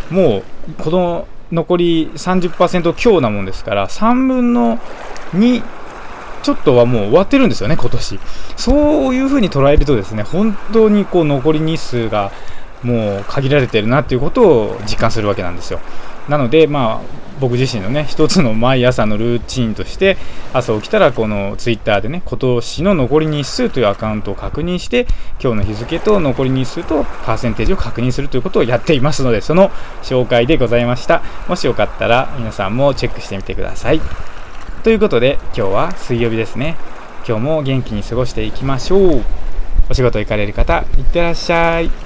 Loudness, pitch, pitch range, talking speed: -15 LUFS, 130 Hz, 110-165 Hz, 340 characters per minute